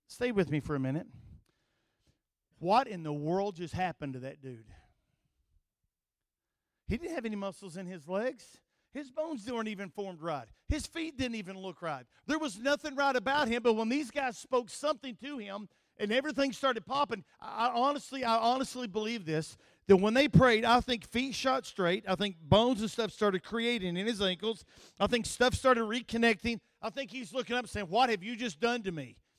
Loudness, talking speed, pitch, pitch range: -32 LUFS, 200 wpm, 225 Hz, 185-255 Hz